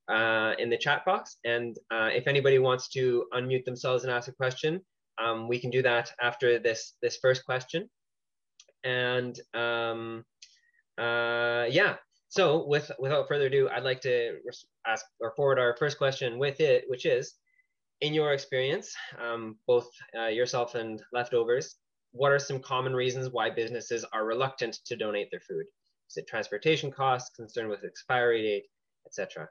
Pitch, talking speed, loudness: 130 Hz, 165 wpm, -29 LUFS